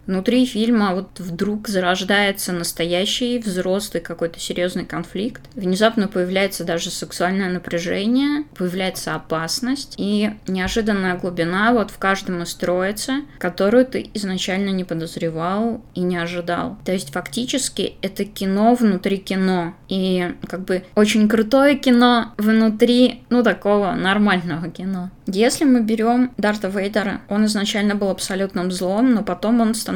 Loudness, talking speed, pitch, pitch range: -20 LUFS, 130 wpm, 195 Hz, 180-220 Hz